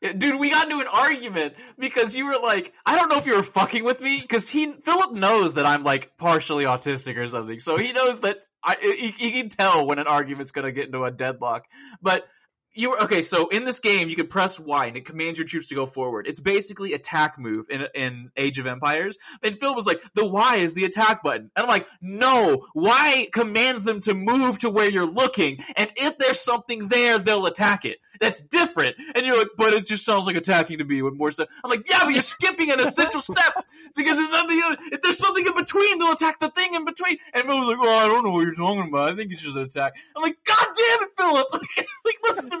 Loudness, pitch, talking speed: -21 LUFS, 225 Hz, 240 wpm